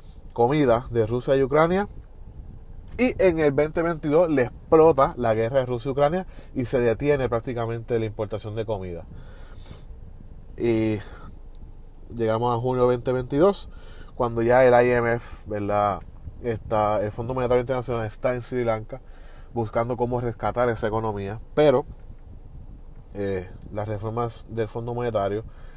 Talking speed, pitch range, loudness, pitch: 130 wpm, 100-125 Hz, -24 LUFS, 115 Hz